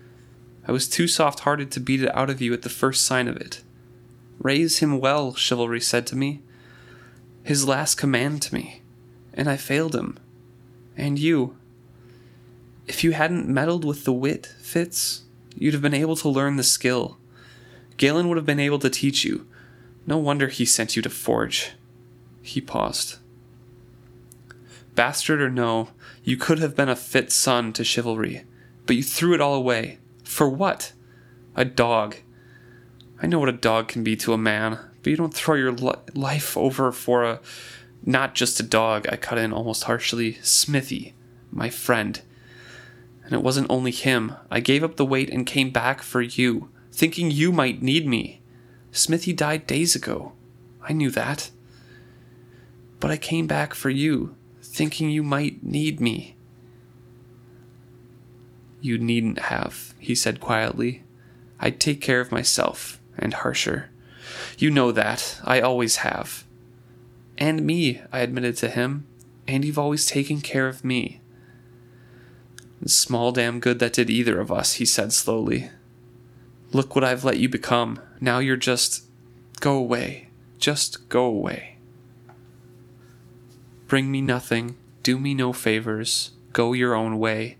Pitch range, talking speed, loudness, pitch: 120-135 Hz, 155 wpm, -23 LUFS, 120 Hz